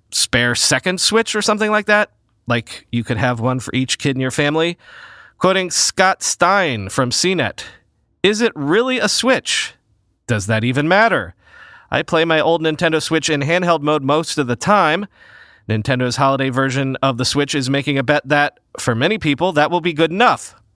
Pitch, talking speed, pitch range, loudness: 150 Hz, 185 wpm, 130-175 Hz, -16 LUFS